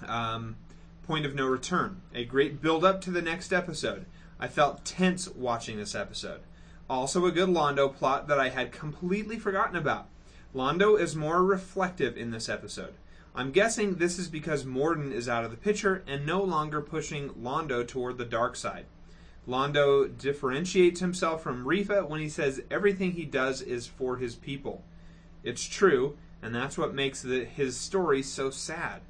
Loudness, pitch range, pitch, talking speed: -29 LUFS, 125-180 Hz, 145 Hz, 170 wpm